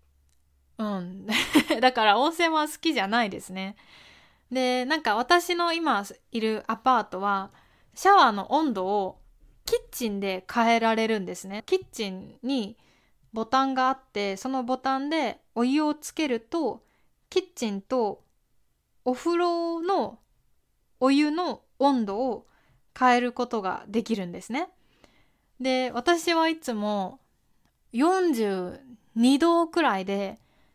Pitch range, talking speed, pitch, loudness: 210-305 Hz, 230 characters per minute, 250 Hz, -26 LUFS